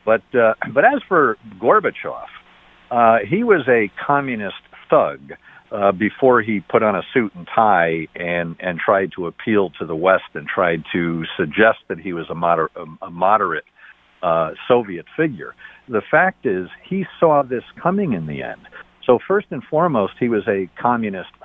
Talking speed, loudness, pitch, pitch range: 170 wpm, -18 LUFS, 95 Hz, 85-120 Hz